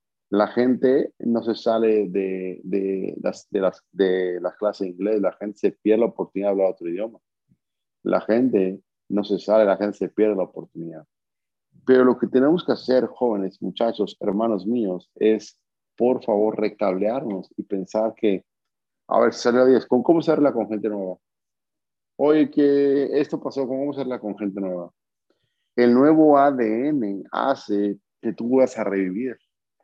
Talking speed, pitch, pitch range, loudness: 165 wpm, 110 Hz, 100-125 Hz, -22 LUFS